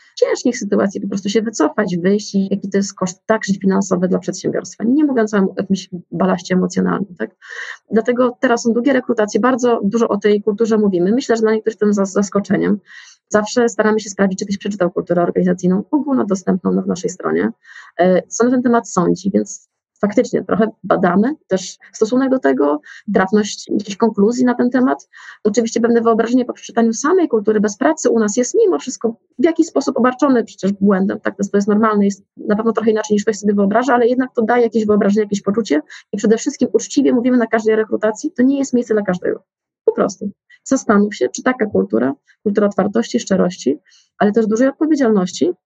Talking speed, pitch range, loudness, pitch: 195 wpm, 200-240 Hz, -16 LUFS, 215 Hz